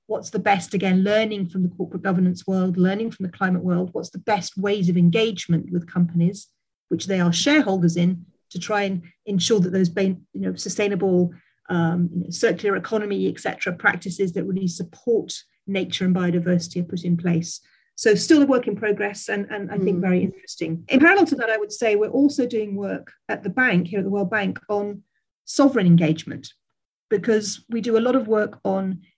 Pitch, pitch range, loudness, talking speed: 190 Hz, 180-210 Hz, -22 LUFS, 195 wpm